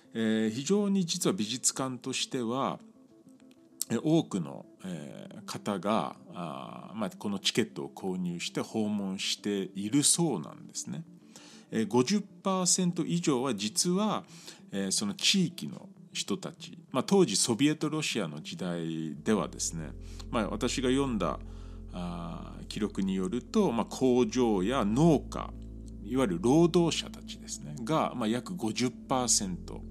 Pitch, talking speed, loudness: 130 Hz, 205 characters per minute, -30 LUFS